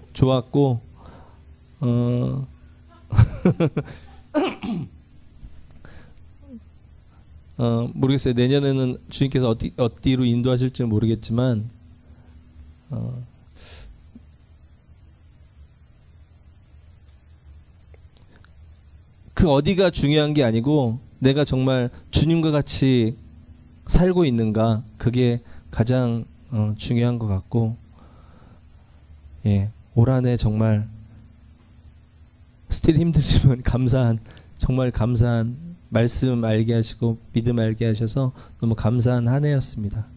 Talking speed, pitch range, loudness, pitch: 170 characters per minute, 80-125 Hz, -21 LUFS, 110 Hz